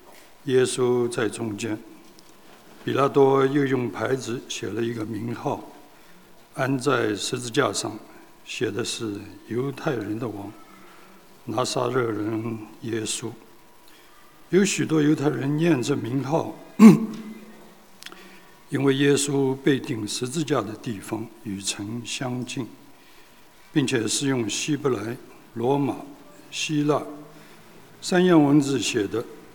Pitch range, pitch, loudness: 115-150 Hz, 135 Hz, -24 LUFS